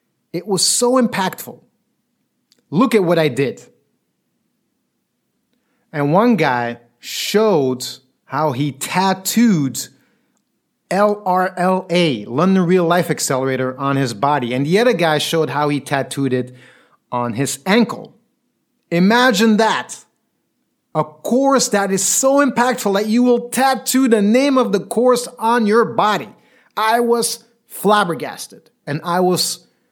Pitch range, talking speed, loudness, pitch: 145-235 Hz, 125 wpm, -16 LUFS, 190 Hz